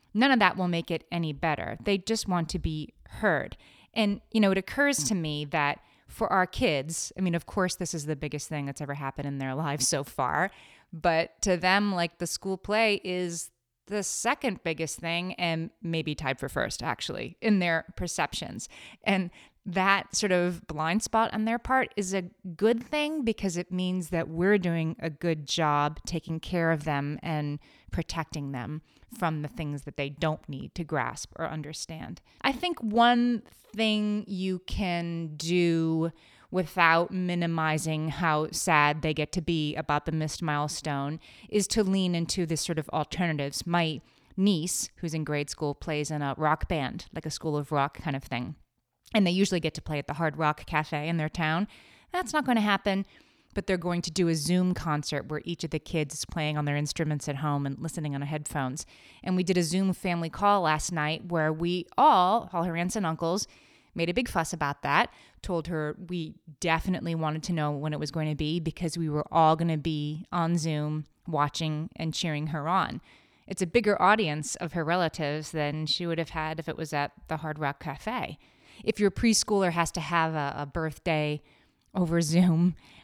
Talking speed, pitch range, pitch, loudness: 195 wpm, 150-185 Hz, 165 Hz, -29 LUFS